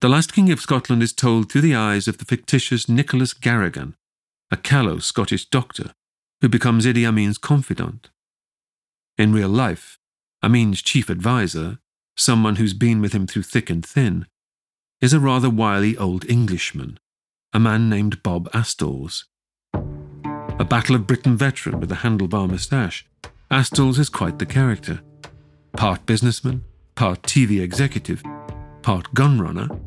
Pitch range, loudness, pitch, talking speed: 105-130 Hz, -19 LUFS, 115 Hz, 145 wpm